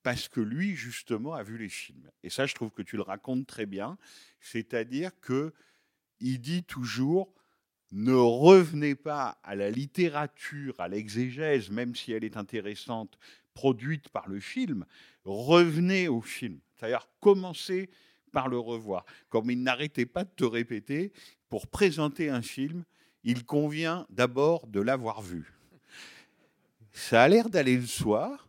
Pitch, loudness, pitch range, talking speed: 130 Hz, -29 LUFS, 115-160 Hz, 150 wpm